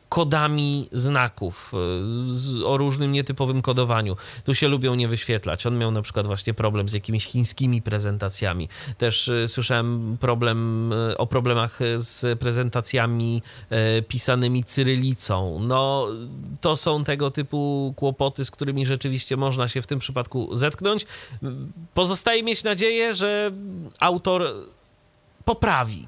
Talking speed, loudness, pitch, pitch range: 115 wpm, -23 LUFS, 125 Hz, 115-140 Hz